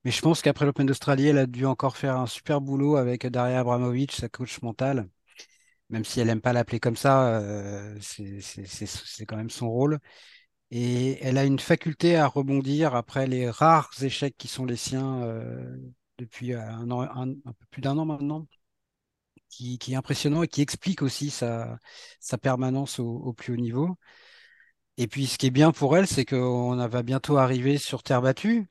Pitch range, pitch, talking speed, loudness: 120-145 Hz, 130 Hz, 200 wpm, -26 LUFS